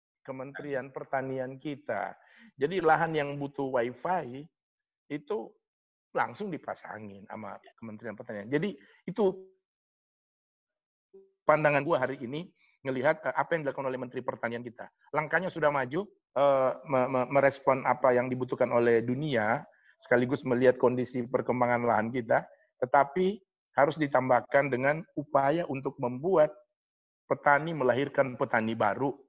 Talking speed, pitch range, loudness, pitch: 115 wpm, 125-155 Hz, -29 LUFS, 135 Hz